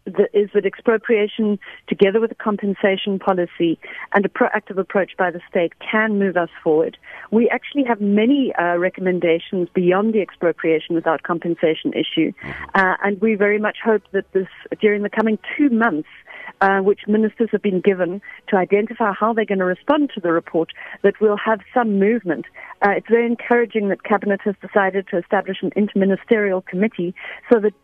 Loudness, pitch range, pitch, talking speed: -19 LUFS, 185-220 Hz, 200 Hz, 170 wpm